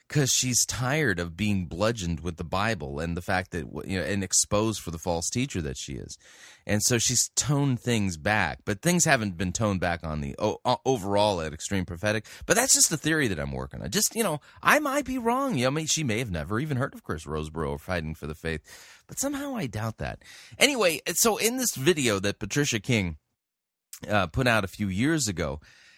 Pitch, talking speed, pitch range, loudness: 105 Hz, 220 wpm, 90-135 Hz, -26 LUFS